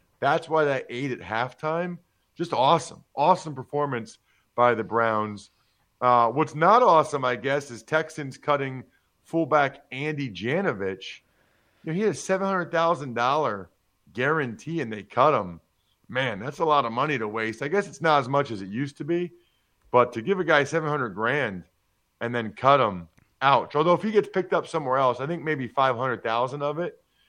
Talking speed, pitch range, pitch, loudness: 190 wpm, 115-160 Hz, 140 Hz, -25 LUFS